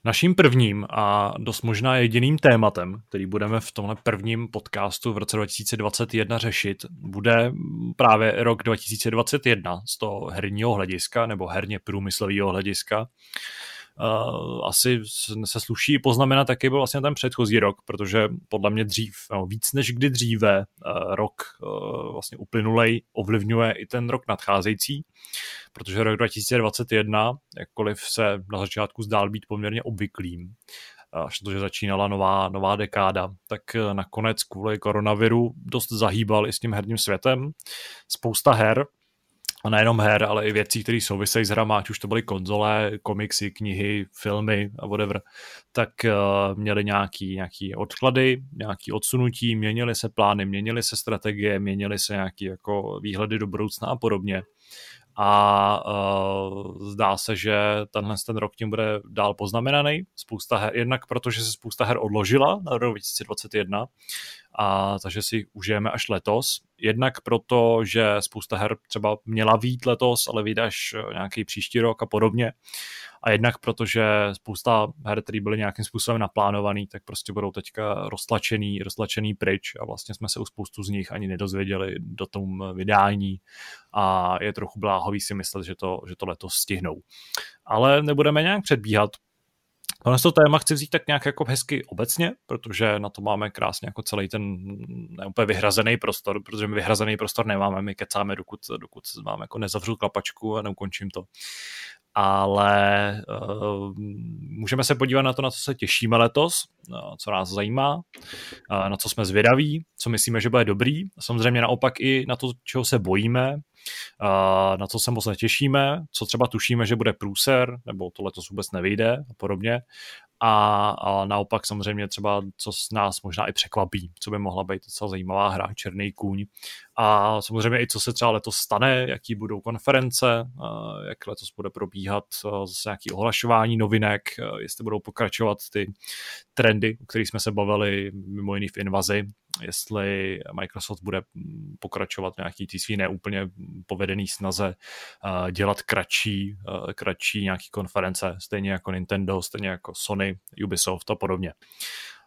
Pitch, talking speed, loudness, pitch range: 105 Hz, 150 wpm, -24 LUFS, 100-115 Hz